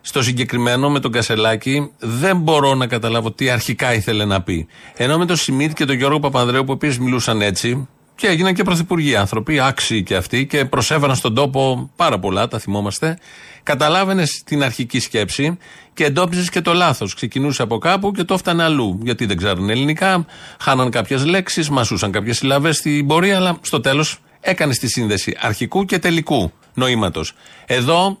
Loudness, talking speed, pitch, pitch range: -17 LUFS, 170 wpm, 135 Hz, 120-160 Hz